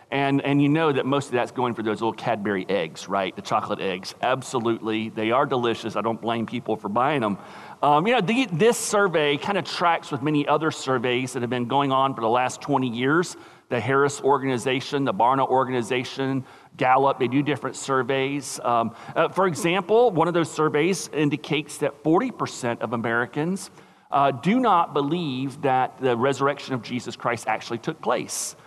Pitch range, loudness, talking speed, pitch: 125-150 Hz, -23 LUFS, 185 wpm, 135 Hz